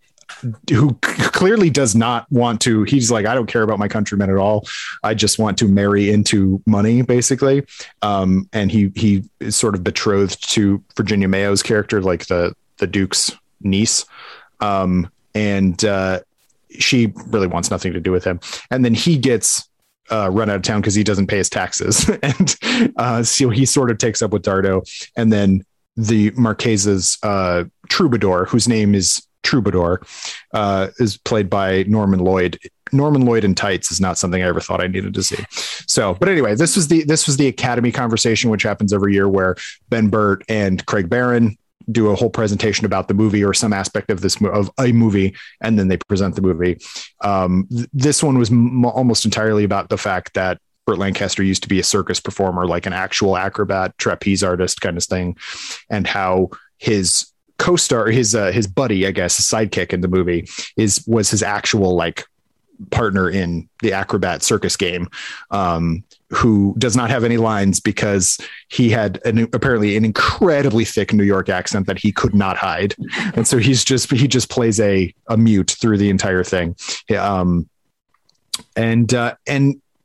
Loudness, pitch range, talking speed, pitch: -17 LUFS, 95-115 Hz, 185 wpm, 105 Hz